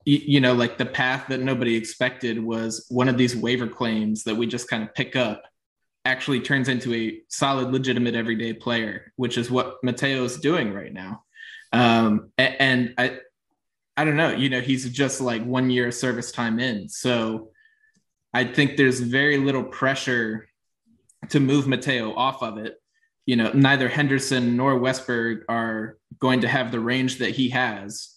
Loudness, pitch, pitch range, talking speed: -23 LUFS, 125 Hz, 115-135 Hz, 175 wpm